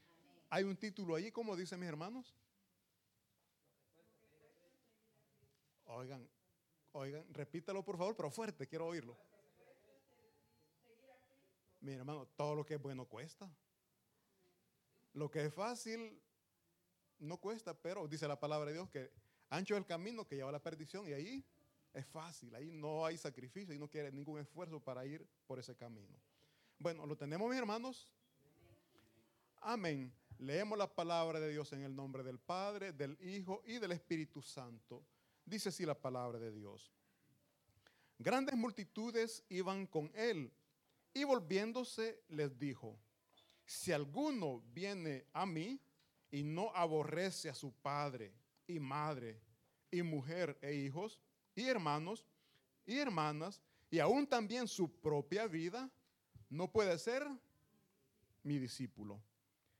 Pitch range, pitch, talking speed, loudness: 140-195 Hz, 155 Hz, 135 wpm, -44 LUFS